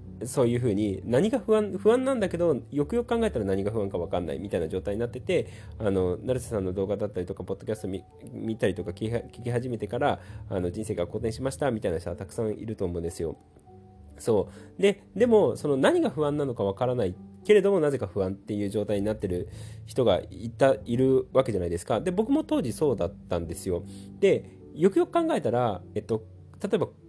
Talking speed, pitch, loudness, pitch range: 435 characters per minute, 110 Hz, -27 LUFS, 95-135 Hz